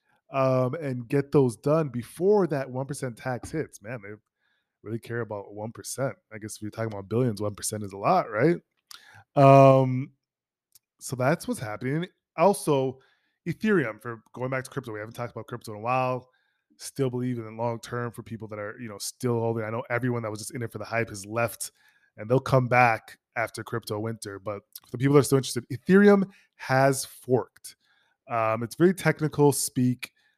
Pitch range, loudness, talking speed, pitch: 110-135 Hz, -26 LUFS, 195 wpm, 125 Hz